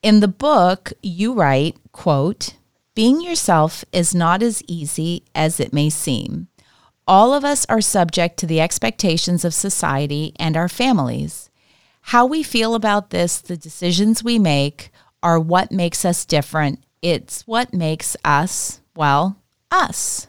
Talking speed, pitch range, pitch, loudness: 145 wpm, 155-210 Hz, 175 Hz, -18 LUFS